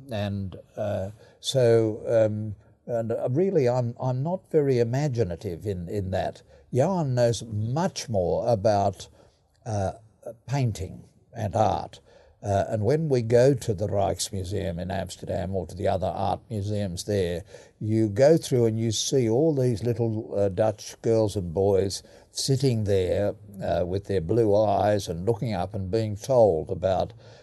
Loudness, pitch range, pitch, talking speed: -25 LUFS, 100-120 Hz, 110 Hz, 150 wpm